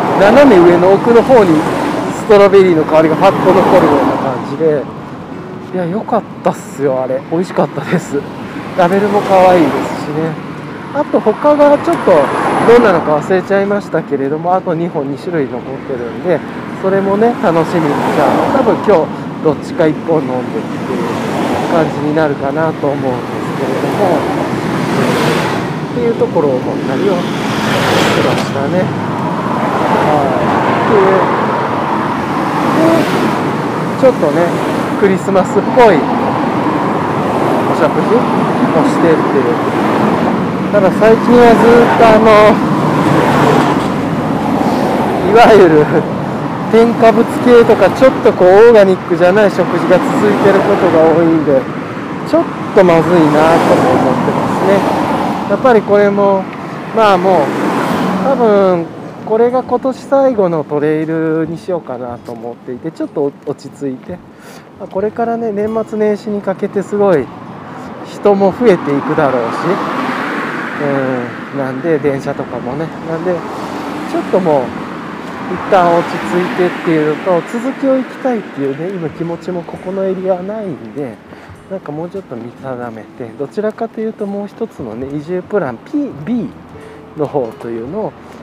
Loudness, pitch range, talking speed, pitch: -12 LUFS, 155-220 Hz, 285 characters per minute, 185 Hz